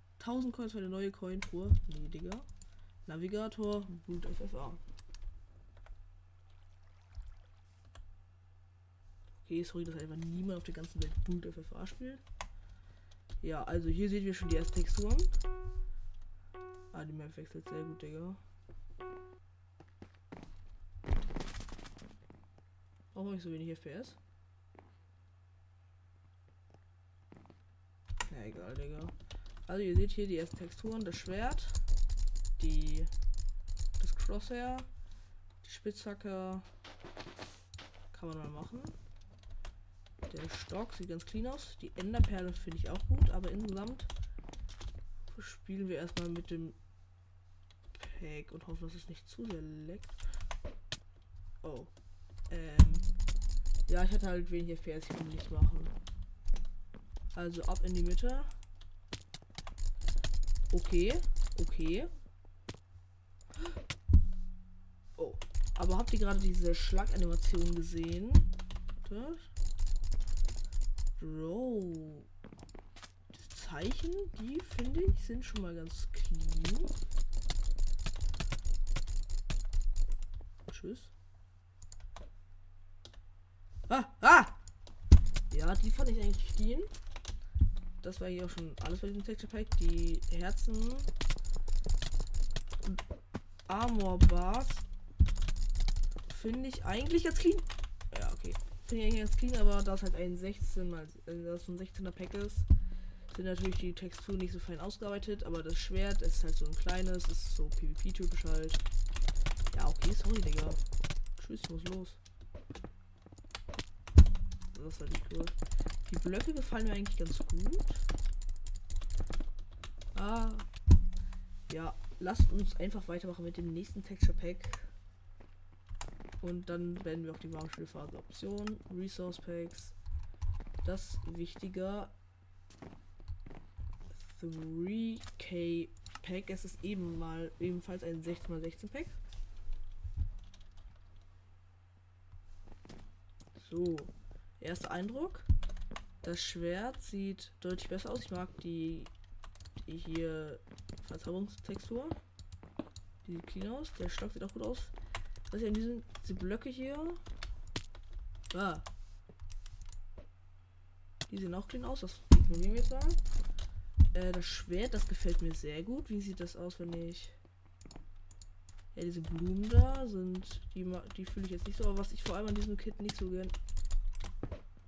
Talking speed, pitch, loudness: 115 wpm, 90 Hz, -38 LUFS